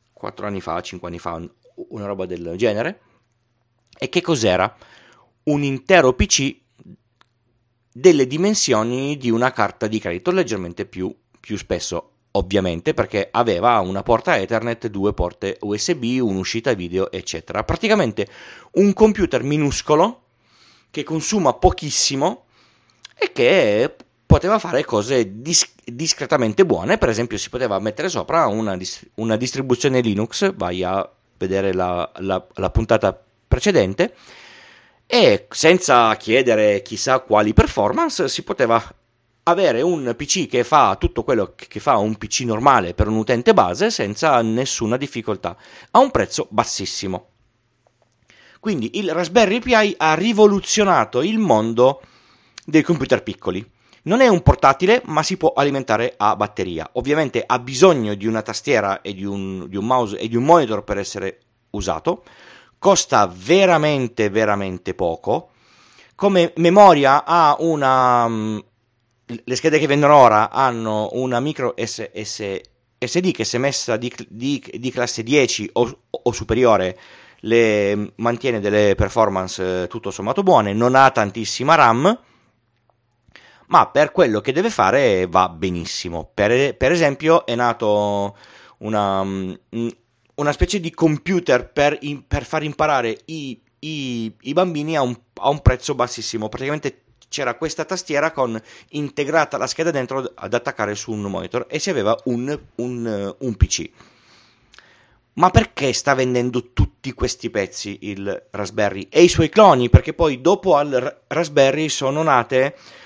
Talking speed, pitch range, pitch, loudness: 135 wpm, 105-150 Hz, 120 Hz, -18 LUFS